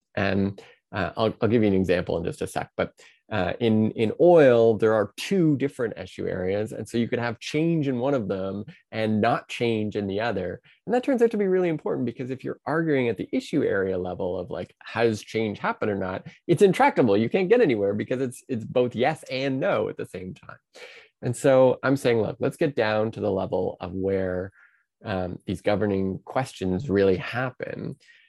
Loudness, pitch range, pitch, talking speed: -24 LUFS, 100-140 Hz, 120 Hz, 210 wpm